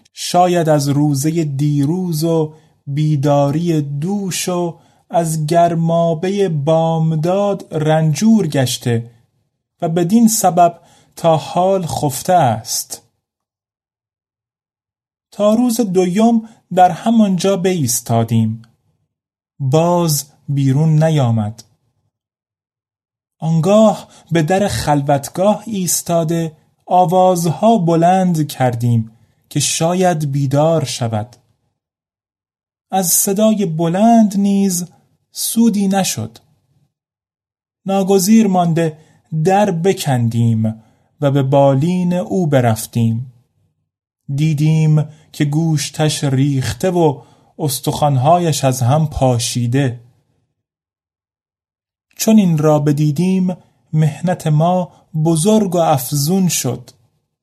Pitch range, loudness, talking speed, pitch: 125-175 Hz, -15 LUFS, 80 wpm, 150 Hz